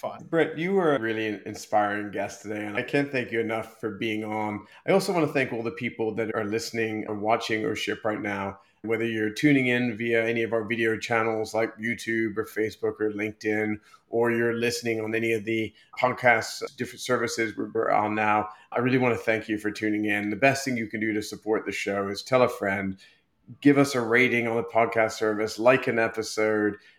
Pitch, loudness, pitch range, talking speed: 110 Hz, -26 LUFS, 105-120 Hz, 215 wpm